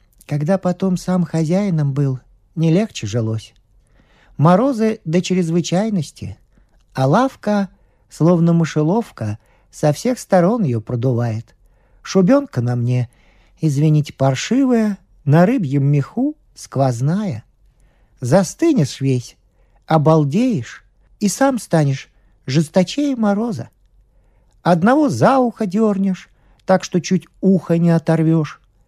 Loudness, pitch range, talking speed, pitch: -17 LUFS, 120-190 Hz, 100 wpm, 160 Hz